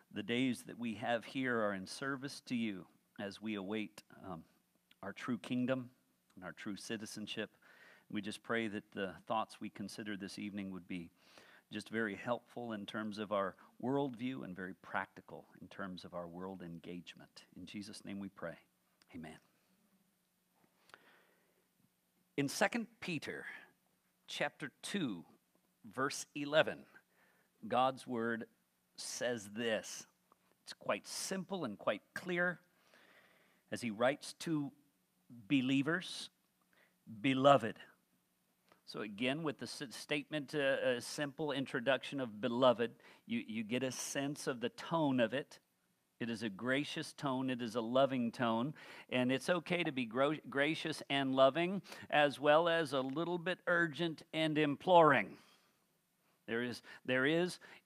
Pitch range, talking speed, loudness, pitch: 110-150 Hz, 140 wpm, -38 LUFS, 130 Hz